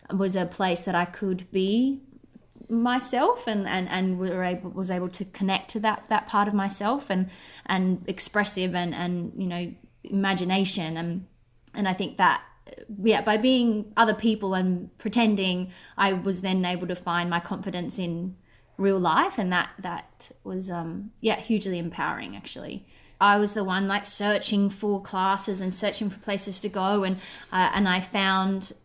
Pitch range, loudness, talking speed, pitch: 185-210 Hz, -26 LUFS, 170 wpm, 195 Hz